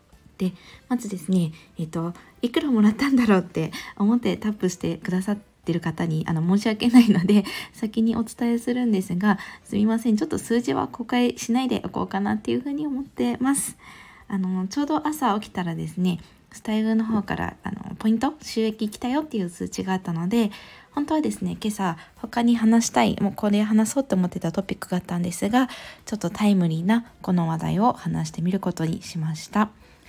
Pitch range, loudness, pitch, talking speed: 180-235 Hz, -24 LUFS, 205 Hz, 405 characters per minute